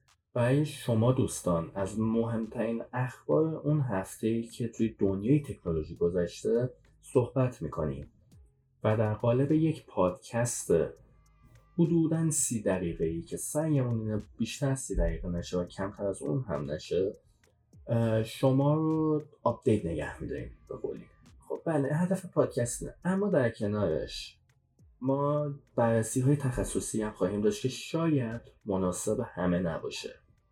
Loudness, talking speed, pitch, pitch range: -31 LUFS, 120 wpm, 115 Hz, 100-140 Hz